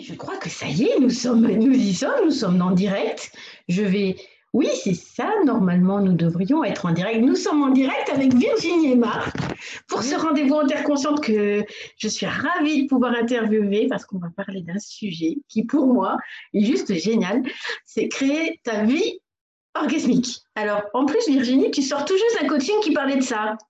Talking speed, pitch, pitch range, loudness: 200 wpm, 250 Hz, 205-290 Hz, -21 LUFS